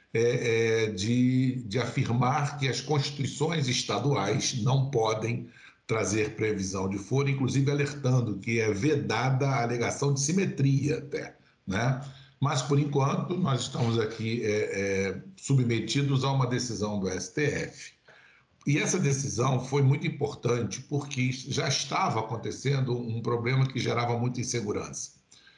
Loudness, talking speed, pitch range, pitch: -28 LUFS, 125 wpm, 115-140 Hz, 130 Hz